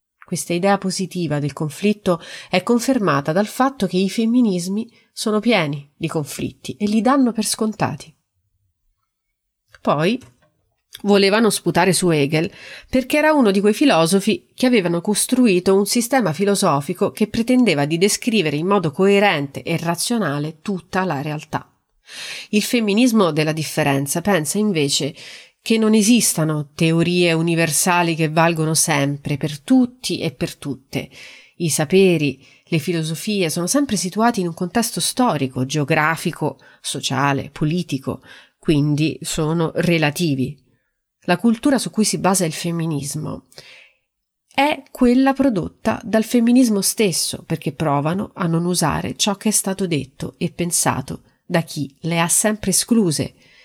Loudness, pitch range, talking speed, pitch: -19 LUFS, 155-210 Hz, 130 wpm, 175 Hz